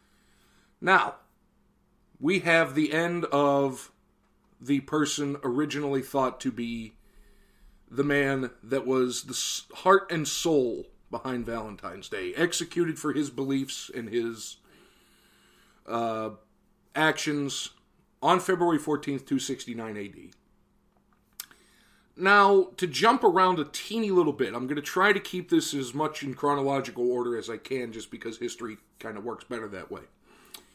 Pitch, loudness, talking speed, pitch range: 140 Hz, -27 LUFS, 135 wpm, 125-165 Hz